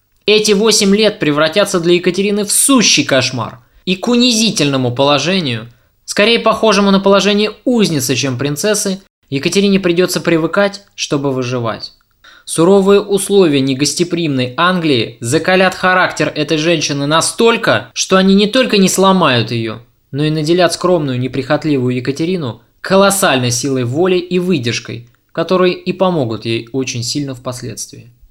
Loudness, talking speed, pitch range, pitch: -13 LUFS, 125 wpm, 135-195 Hz, 170 Hz